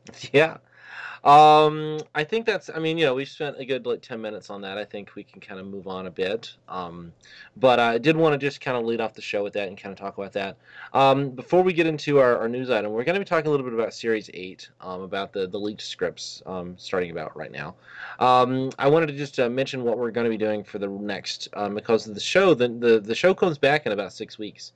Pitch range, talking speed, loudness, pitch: 100-145 Hz, 270 wpm, -23 LUFS, 120 Hz